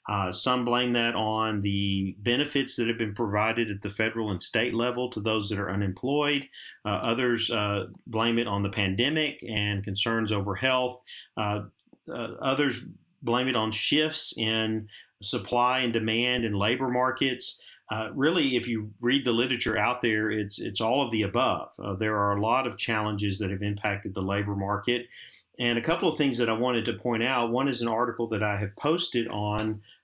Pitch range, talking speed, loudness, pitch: 105-125 Hz, 190 wpm, -27 LUFS, 115 Hz